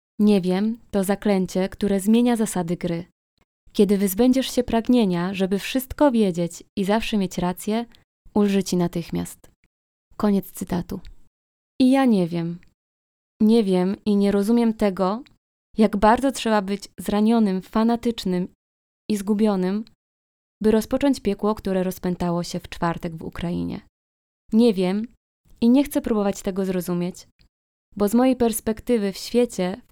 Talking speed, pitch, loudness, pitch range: 130 wpm, 200 Hz, -22 LUFS, 180-225 Hz